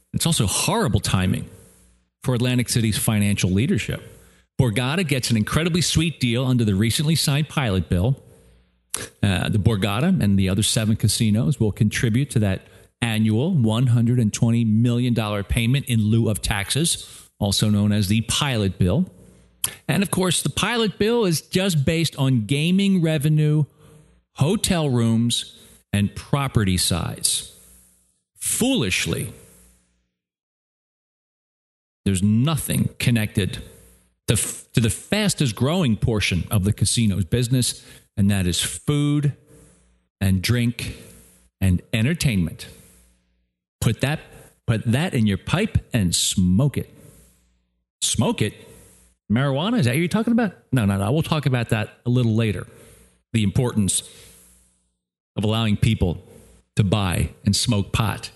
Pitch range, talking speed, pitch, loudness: 100-140 Hz, 130 wpm, 115 Hz, -21 LUFS